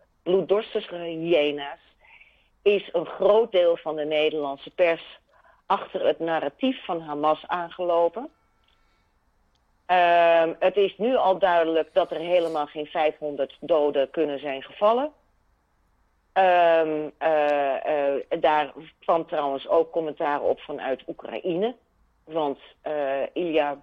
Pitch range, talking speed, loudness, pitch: 145-175 Hz, 115 wpm, -24 LUFS, 160 Hz